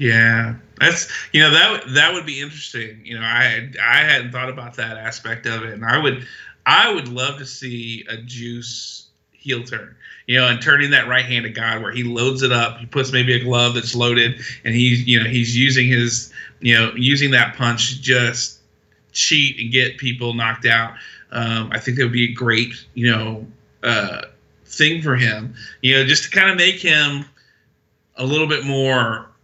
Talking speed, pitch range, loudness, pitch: 200 wpm, 115-130 Hz, -16 LUFS, 120 Hz